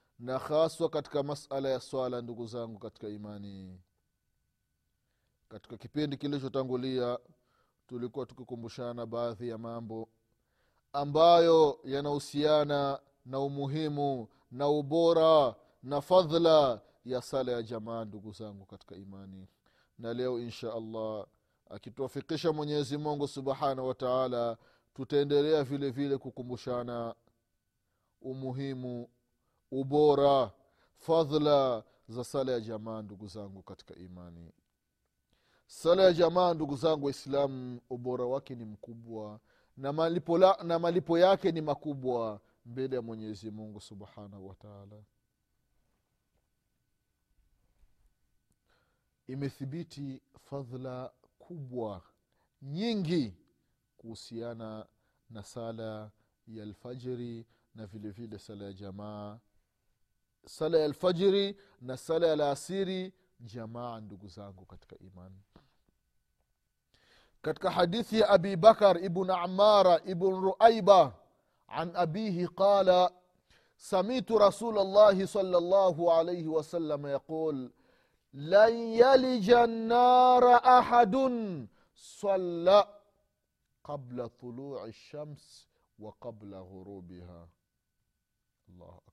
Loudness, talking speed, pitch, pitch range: -28 LUFS, 90 wpm, 130 Hz, 110-165 Hz